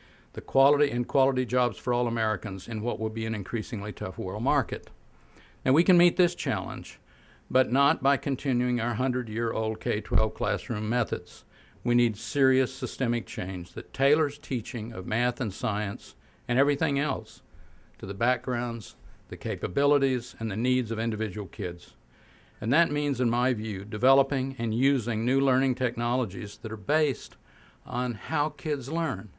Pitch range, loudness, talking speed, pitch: 110-135 Hz, -27 LUFS, 165 wpm, 120 Hz